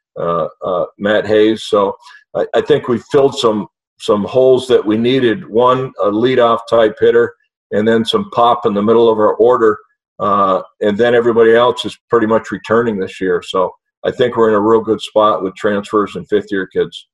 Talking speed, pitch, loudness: 195 wpm, 120 Hz, -14 LUFS